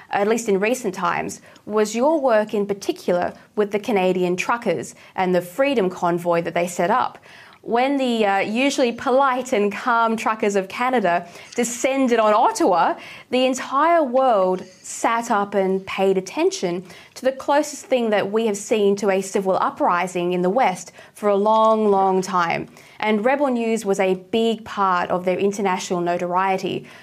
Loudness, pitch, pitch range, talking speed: -20 LUFS, 205 Hz, 185-245 Hz, 165 wpm